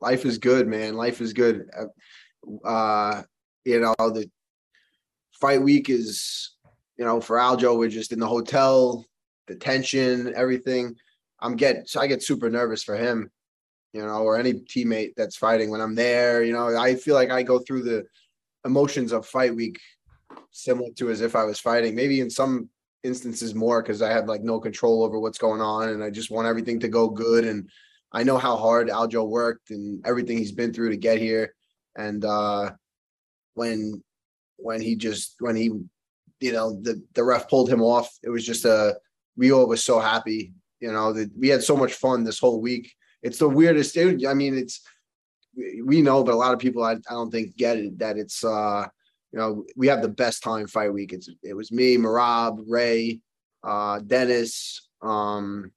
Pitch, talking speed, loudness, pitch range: 115 Hz, 195 wpm, -23 LUFS, 110-125 Hz